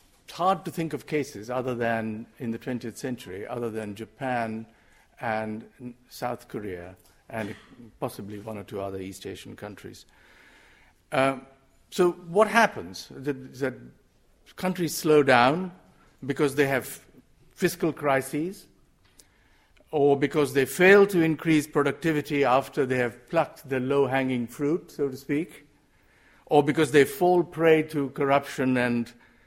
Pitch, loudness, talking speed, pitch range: 135 Hz, -25 LUFS, 130 wpm, 120-150 Hz